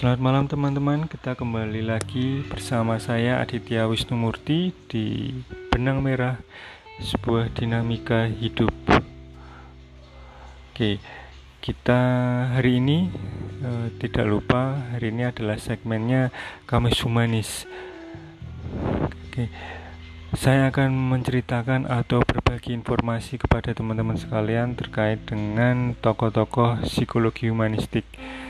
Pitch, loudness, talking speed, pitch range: 115 Hz, -24 LUFS, 95 wpm, 110-125 Hz